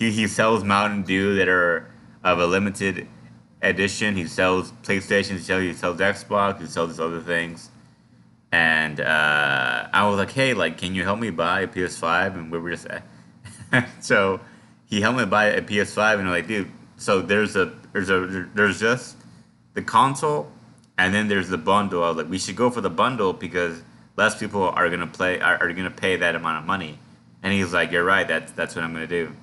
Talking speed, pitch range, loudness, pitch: 210 wpm, 85-100 Hz, -22 LUFS, 95 Hz